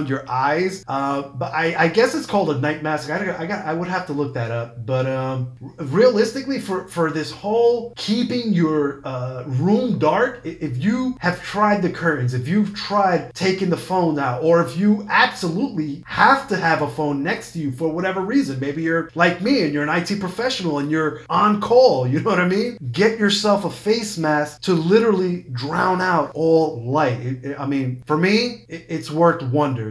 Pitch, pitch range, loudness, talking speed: 165 Hz, 145-200 Hz, -20 LUFS, 205 wpm